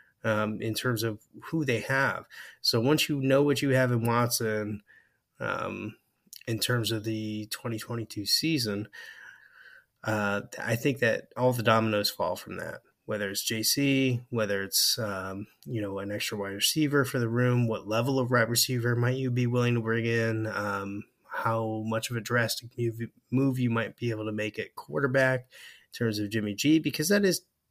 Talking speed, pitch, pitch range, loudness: 180 wpm, 115 Hz, 110-125 Hz, -28 LUFS